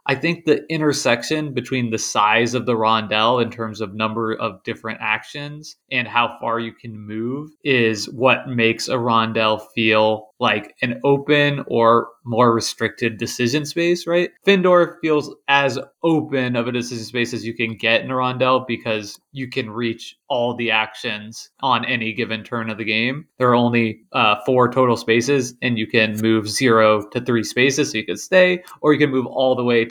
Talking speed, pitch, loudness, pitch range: 190 wpm, 120 Hz, -19 LUFS, 110-135 Hz